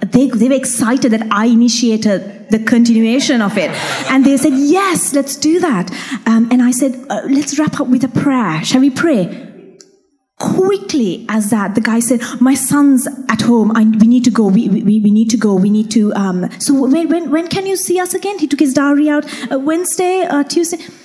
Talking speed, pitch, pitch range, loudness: 220 wpm, 255 Hz, 225-290 Hz, -13 LUFS